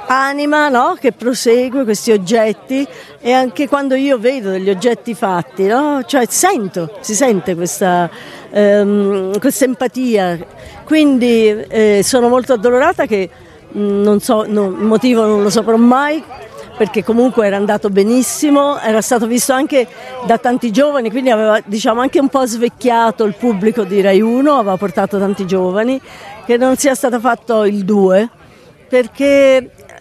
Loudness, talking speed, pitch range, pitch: -13 LUFS, 150 wpm, 205-260 Hz, 230 Hz